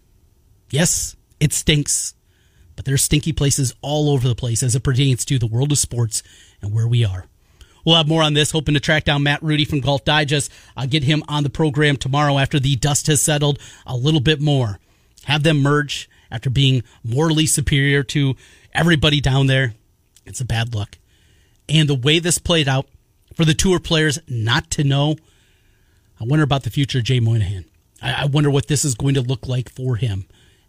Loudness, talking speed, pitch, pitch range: -18 LUFS, 195 wpm, 135 Hz, 115-150 Hz